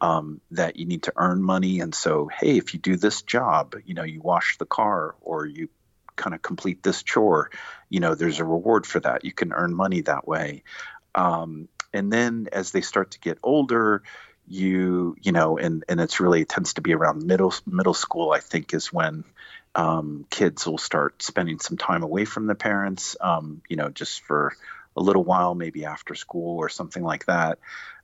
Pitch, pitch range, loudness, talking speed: 90 Hz, 80-100 Hz, -24 LUFS, 205 wpm